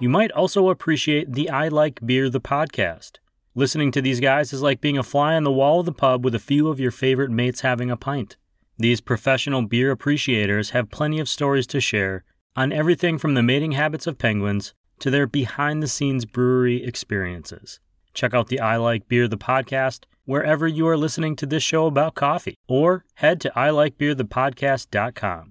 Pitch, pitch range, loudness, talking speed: 135 Hz, 125-150 Hz, -21 LUFS, 190 wpm